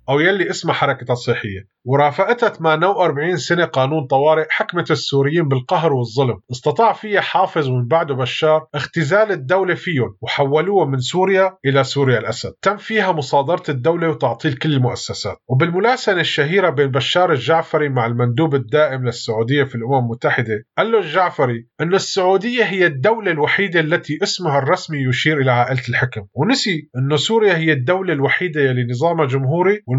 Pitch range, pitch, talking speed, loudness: 130-180 Hz, 150 Hz, 140 wpm, -17 LUFS